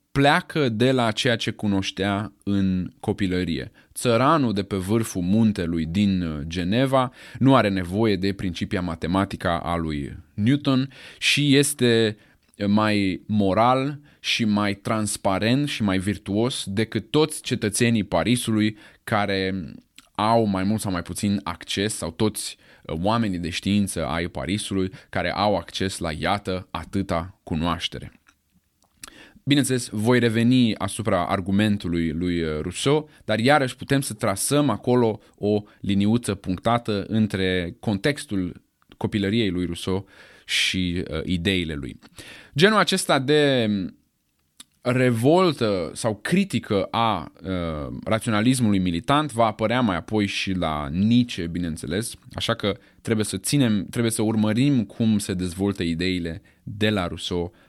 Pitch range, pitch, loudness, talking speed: 95-115 Hz, 105 Hz, -23 LUFS, 125 wpm